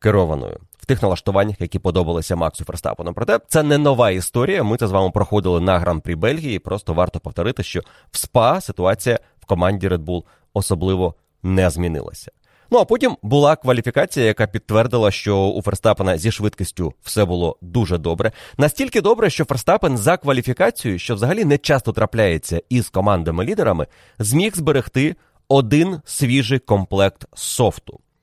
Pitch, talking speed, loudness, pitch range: 105 Hz, 150 wpm, -19 LUFS, 90-125 Hz